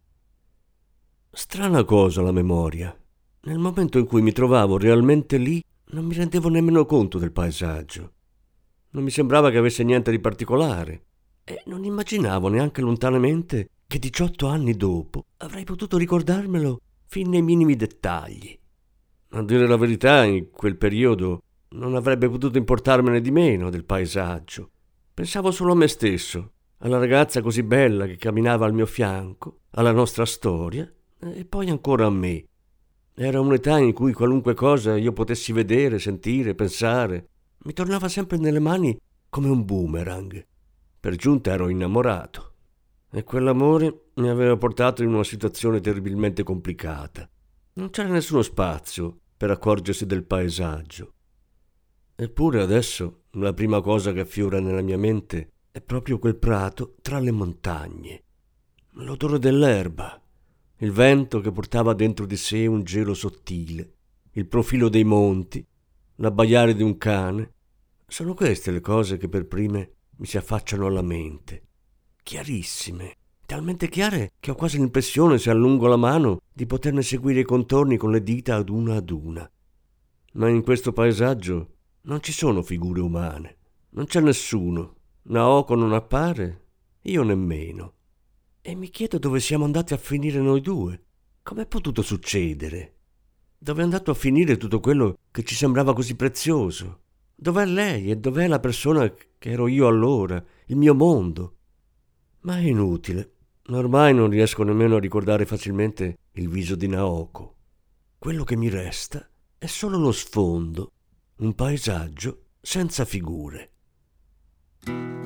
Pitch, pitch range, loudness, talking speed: 110 Hz, 90-135 Hz, -22 LUFS, 145 wpm